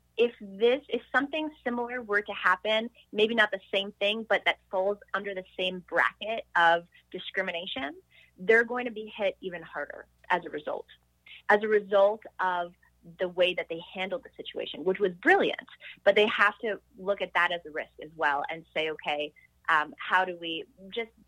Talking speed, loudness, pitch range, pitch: 185 wpm, -28 LUFS, 175-225 Hz, 200 Hz